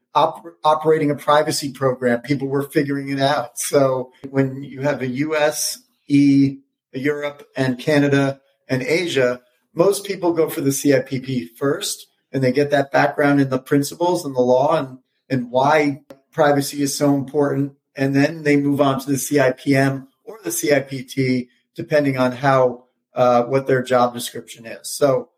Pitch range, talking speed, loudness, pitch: 130-145 Hz, 160 wpm, -19 LUFS, 140 Hz